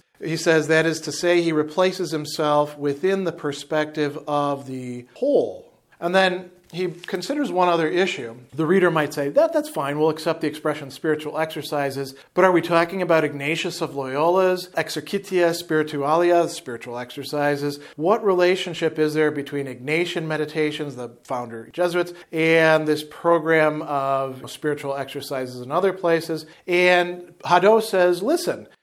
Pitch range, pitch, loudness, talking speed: 145-175 Hz, 160 Hz, -22 LUFS, 145 wpm